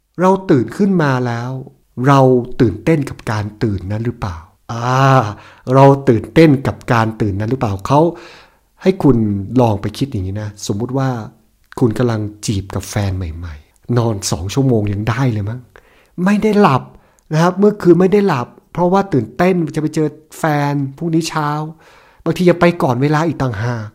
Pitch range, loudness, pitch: 110-160 Hz, -15 LUFS, 130 Hz